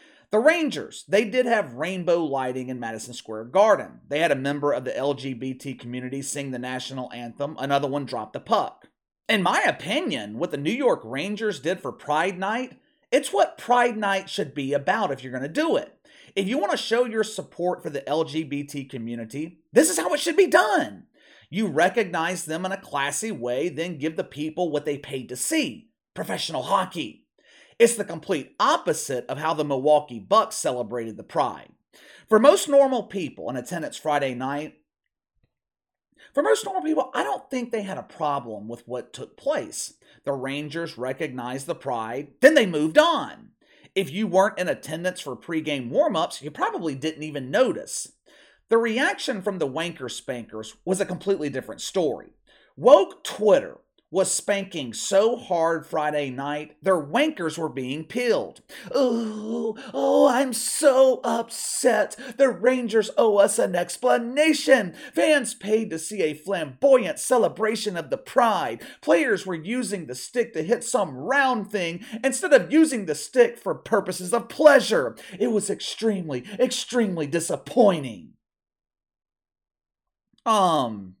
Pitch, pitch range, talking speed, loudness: 185 Hz, 140-240 Hz, 160 wpm, -24 LUFS